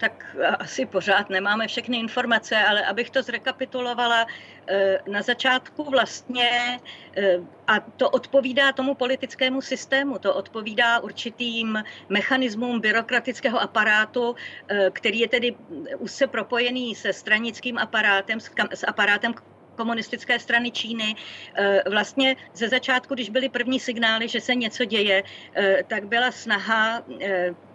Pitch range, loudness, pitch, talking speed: 210-250 Hz, -23 LUFS, 235 Hz, 120 wpm